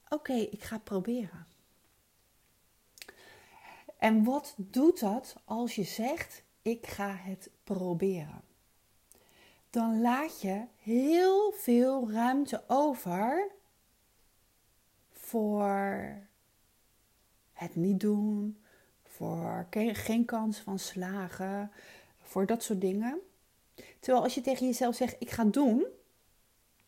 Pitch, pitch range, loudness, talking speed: 220 Hz, 195-255 Hz, -32 LUFS, 105 wpm